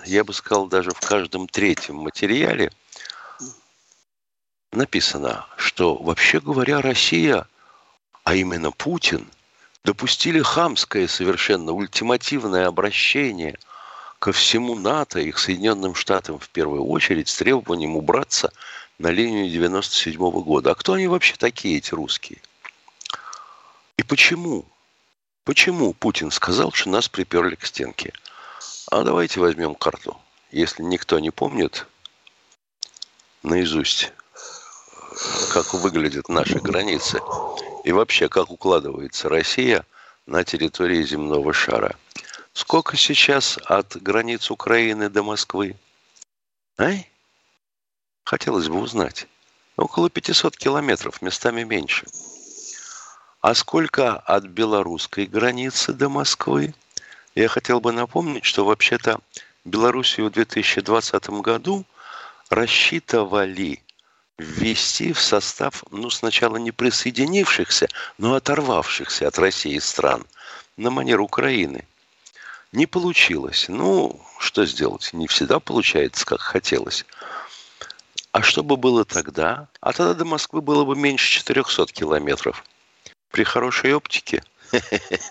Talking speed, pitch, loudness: 110 wpm, 115 Hz, -20 LUFS